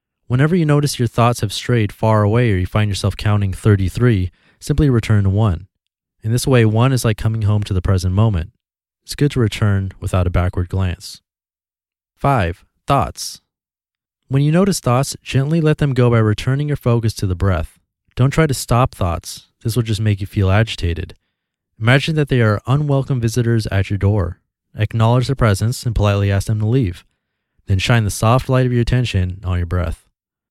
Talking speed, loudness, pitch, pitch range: 190 wpm, -17 LUFS, 110 Hz, 95-125 Hz